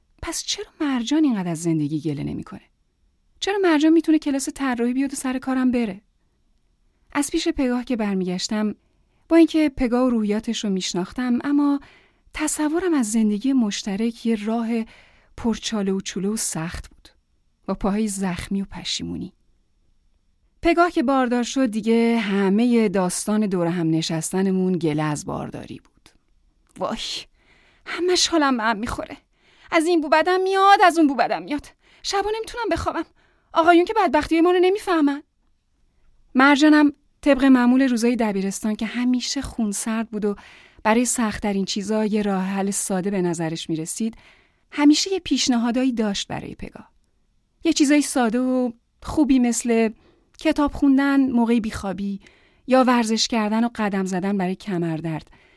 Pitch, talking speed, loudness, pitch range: 240 Hz, 145 wpm, -21 LUFS, 205-295 Hz